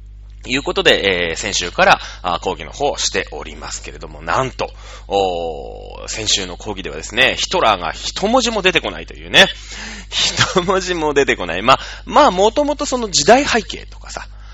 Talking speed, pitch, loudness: 350 characters per minute, 145 Hz, -16 LUFS